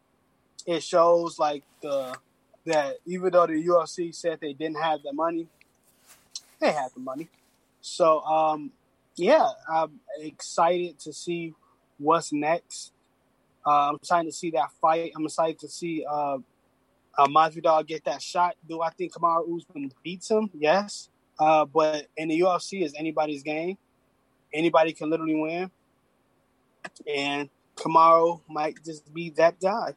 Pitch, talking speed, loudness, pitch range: 160 Hz, 150 wpm, -25 LUFS, 150-170 Hz